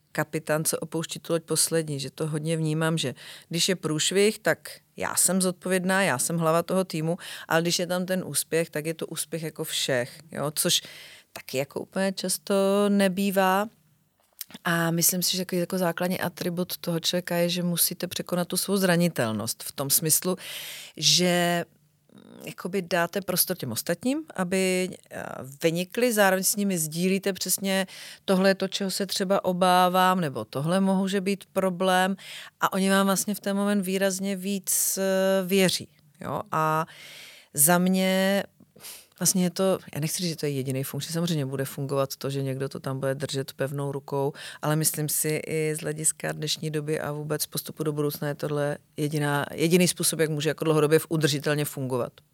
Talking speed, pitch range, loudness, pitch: 170 wpm, 155-190 Hz, -25 LUFS, 175 Hz